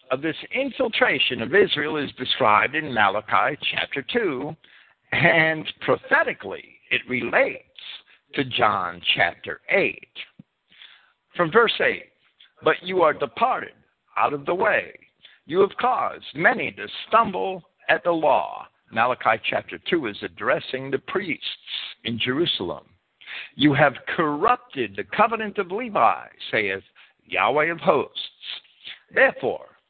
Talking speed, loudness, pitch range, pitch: 120 wpm, -22 LUFS, 150-235 Hz, 170 Hz